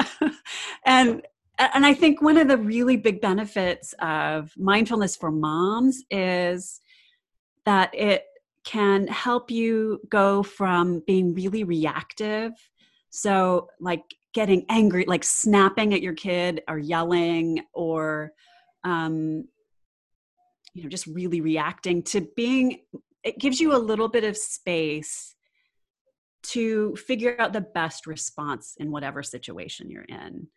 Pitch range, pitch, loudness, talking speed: 175-250 Hz, 200 Hz, -23 LUFS, 125 wpm